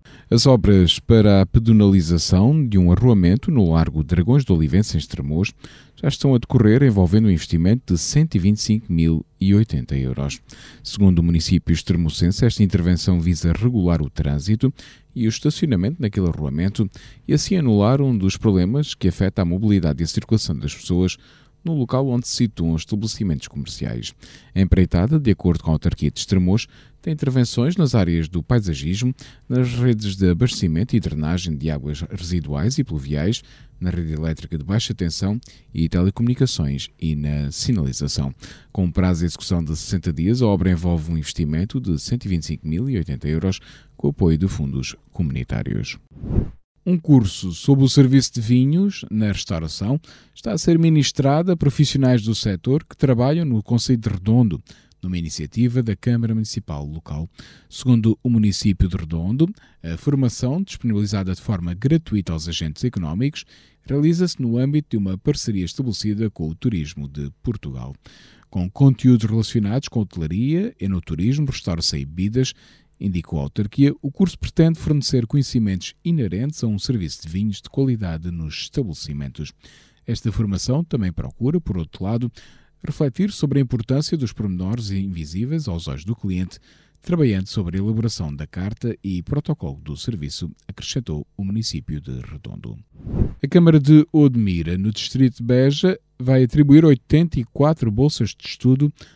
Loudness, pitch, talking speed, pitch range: -20 LUFS, 105 Hz, 155 wpm, 85-130 Hz